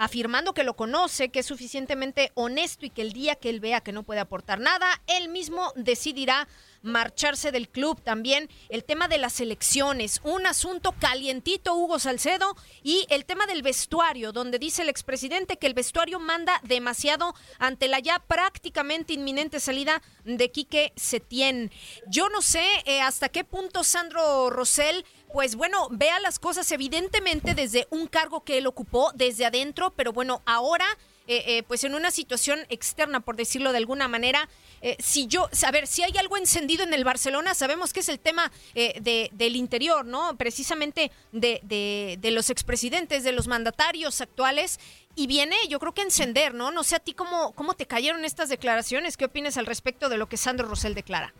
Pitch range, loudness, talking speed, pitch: 245-330 Hz, -25 LUFS, 185 wpm, 285 Hz